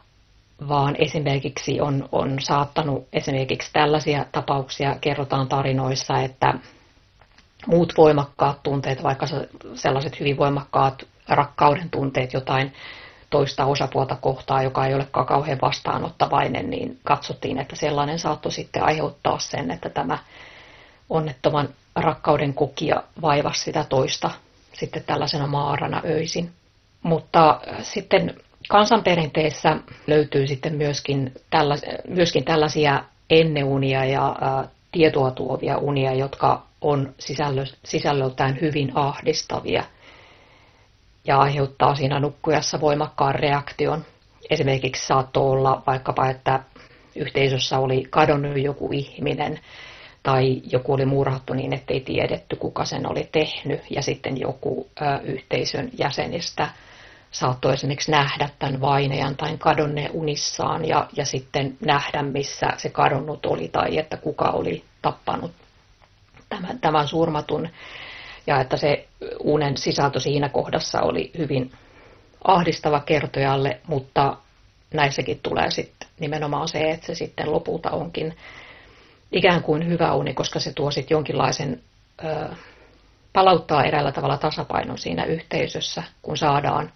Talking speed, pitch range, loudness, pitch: 110 wpm, 135-155 Hz, -22 LUFS, 145 Hz